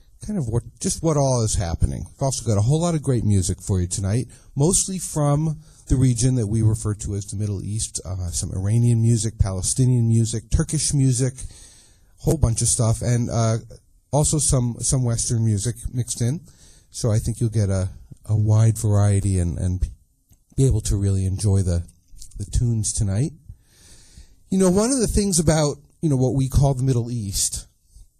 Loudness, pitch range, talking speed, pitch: -21 LUFS, 100-135 Hz, 190 wpm, 115 Hz